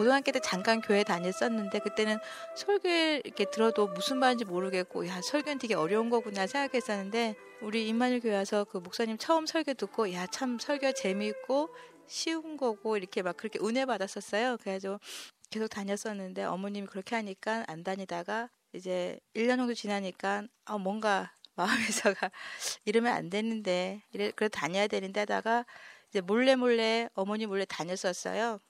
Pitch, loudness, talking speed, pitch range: 215 Hz, -32 LUFS, 360 characters per minute, 195-245 Hz